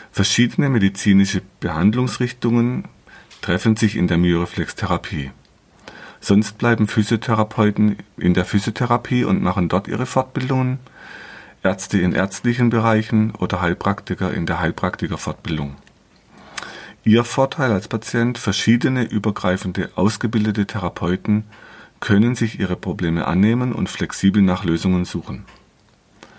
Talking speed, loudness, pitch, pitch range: 105 wpm, -19 LUFS, 105 Hz, 90-115 Hz